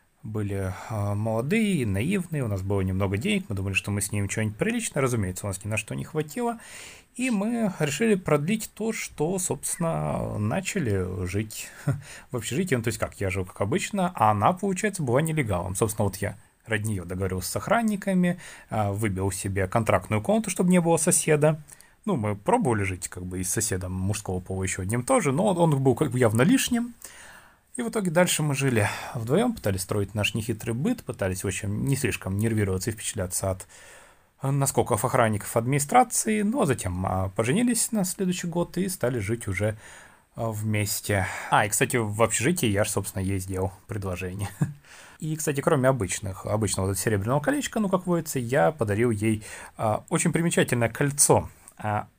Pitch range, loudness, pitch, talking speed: 100-165 Hz, -26 LUFS, 115 Hz, 170 wpm